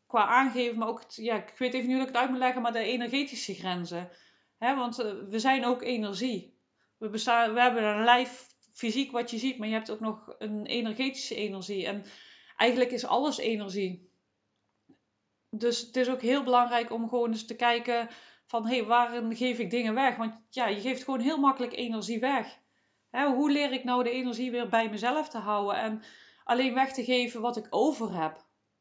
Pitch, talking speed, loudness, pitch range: 240 Hz, 205 wpm, -29 LUFS, 225-255 Hz